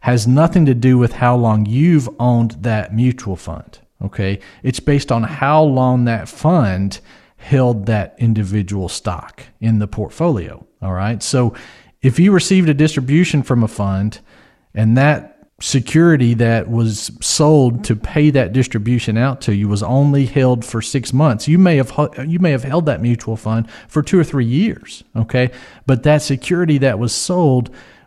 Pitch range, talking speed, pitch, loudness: 110-145 Hz, 170 wpm, 125 Hz, -15 LUFS